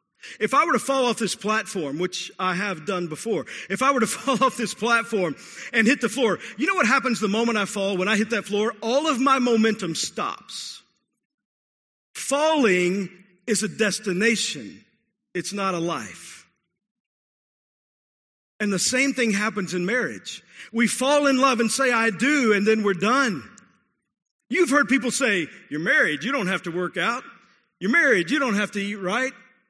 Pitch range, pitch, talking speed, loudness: 195-255 Hz, 225 Hz, 180 wpm, -22 LUFS